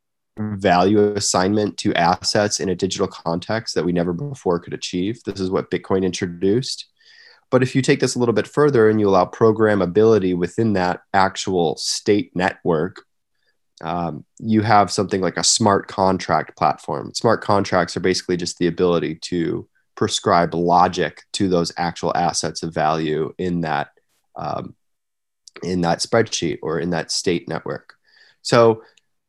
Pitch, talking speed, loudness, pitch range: 95 Hz, 150 wpm, -19 LUFS, 90-110 Hz